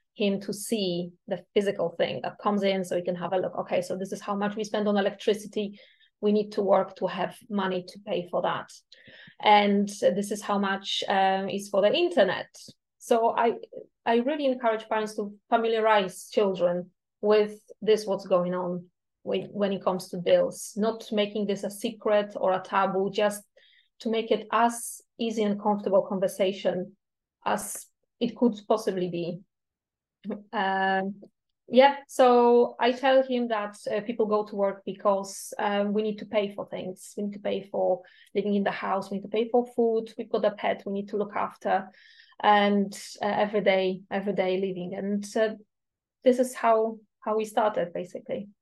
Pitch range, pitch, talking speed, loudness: 195-225 Hz, 205 Hz, 185 wpm, -27 LUFS